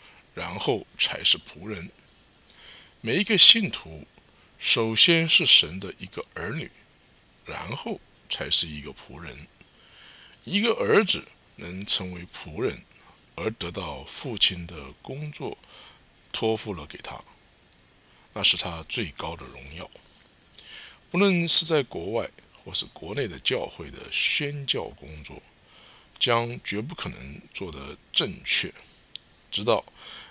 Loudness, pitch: -19 LUFS, 100 Hz